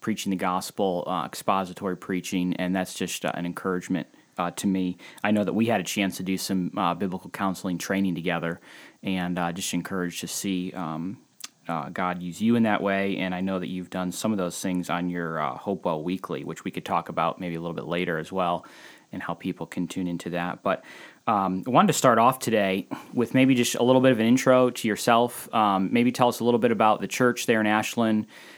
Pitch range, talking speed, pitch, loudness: 90-110 Hz, 230 wpm, 95 Hz, -26 LUFS